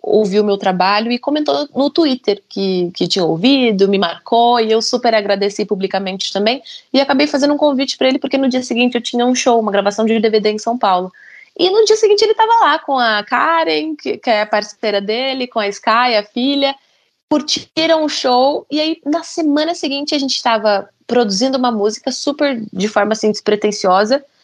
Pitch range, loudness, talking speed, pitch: 210-285 Hz, -15 LUFS, 200 wpm, 240 Hz